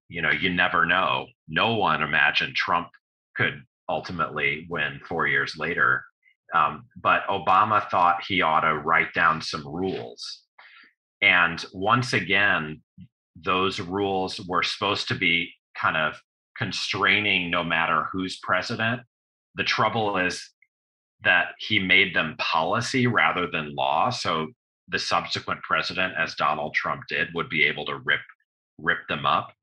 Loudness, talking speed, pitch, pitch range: -23 LUFS, 140 wpm, 90 Hz, 80-105 Hz